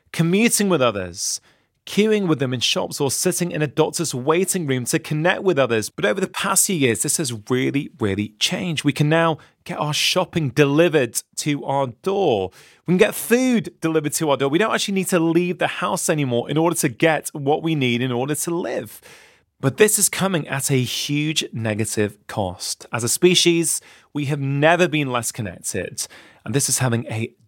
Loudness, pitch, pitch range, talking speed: -20 LUFS, 150 Hz, 130-175 Hz, 200 wpm